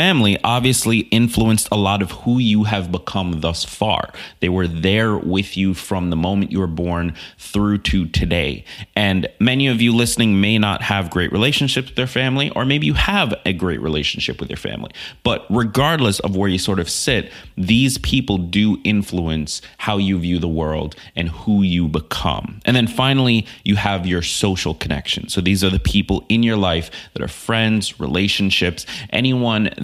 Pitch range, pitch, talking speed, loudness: 90-115 Hz, 100 Hz, 185 wpm, -18 LUFS